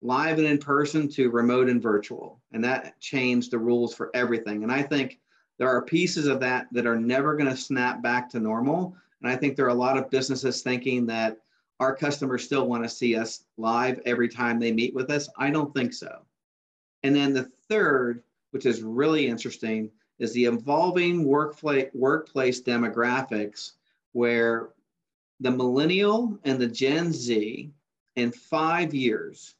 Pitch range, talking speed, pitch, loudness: 120-140 Hz, 170 wpm, 125 Hz, -25 LUFS